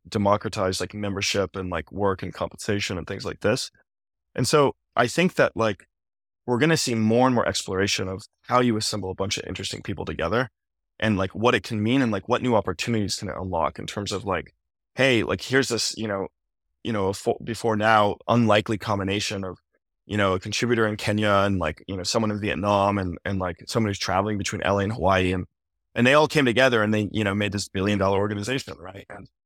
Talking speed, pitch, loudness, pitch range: 220 wpm, 100 Hz, -24 LUFS, 95-110 Hz